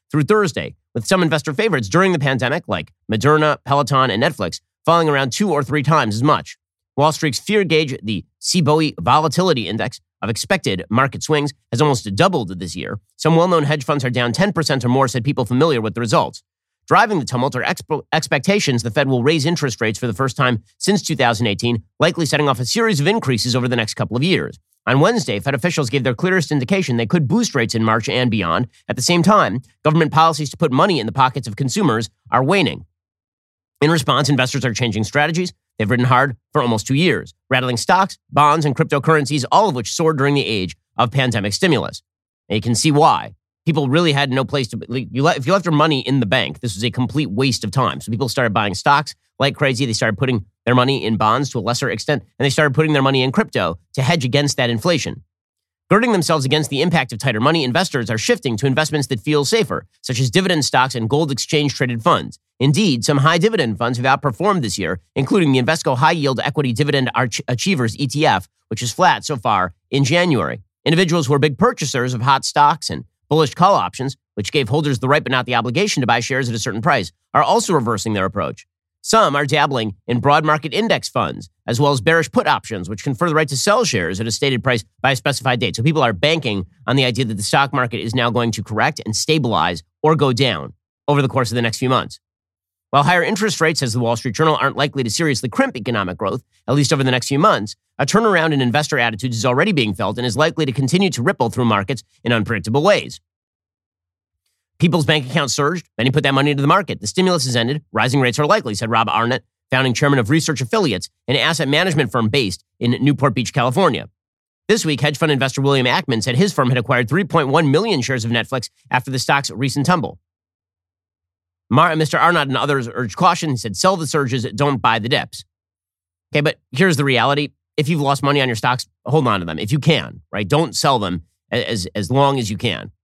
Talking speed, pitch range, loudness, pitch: 220 wpm, 115-150 Hz, -17 LUFS, 135 Hz